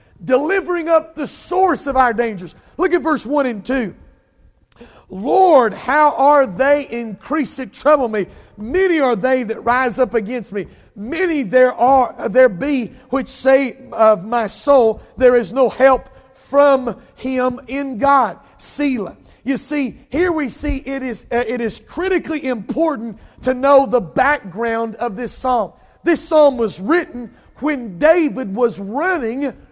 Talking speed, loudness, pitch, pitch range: 150 wpm, -17 LUFS, 260 Hz, 235-290 Hz